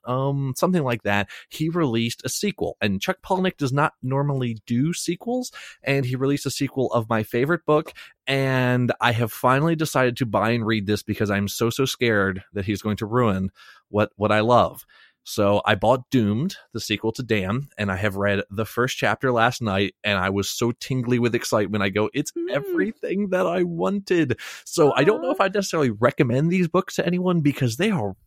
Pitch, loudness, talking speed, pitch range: 125 Hz, -23 LUFS, 200 wpm, 105-150 Hz